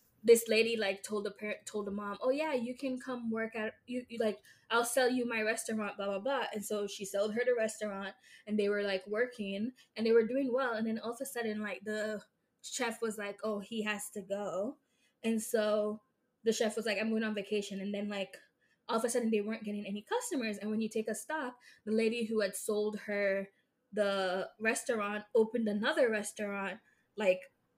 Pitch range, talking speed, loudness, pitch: 205-240 Hz, 215 wpm, -35 LUFS, 220 Hz